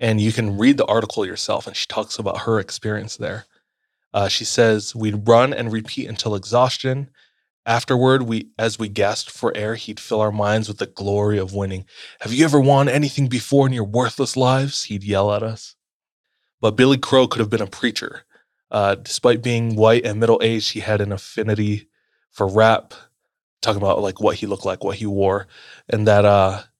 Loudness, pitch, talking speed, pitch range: -19 LUFS, 110 Hz, 195 wpm, 105-125 Hz